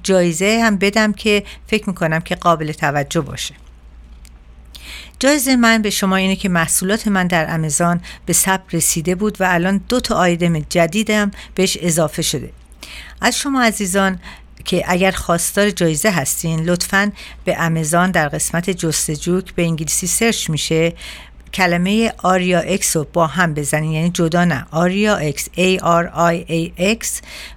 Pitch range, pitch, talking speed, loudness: 160-195 Hz, 175 Hz, 150 wpm, -16 LUFS